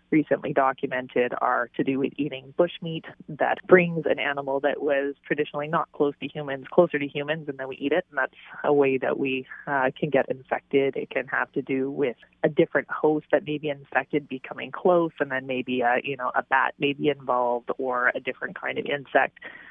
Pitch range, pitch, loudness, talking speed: 135-150 Hz, 140 Hz, -25 LUFS, 210 wpm